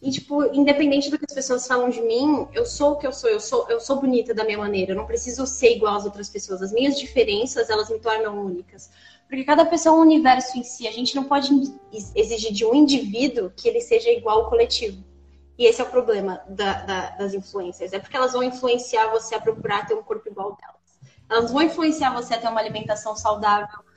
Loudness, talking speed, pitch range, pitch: -21 LUFS, 235 wpm, 215-285 Hz, 245 Hz